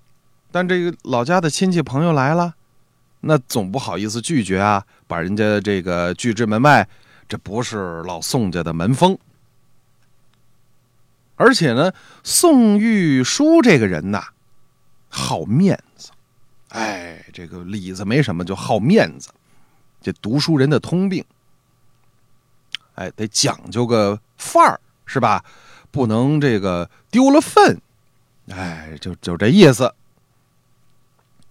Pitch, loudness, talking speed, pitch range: 125 Hz, -17 LUFS, 180 characters per minute, 105-145 Hz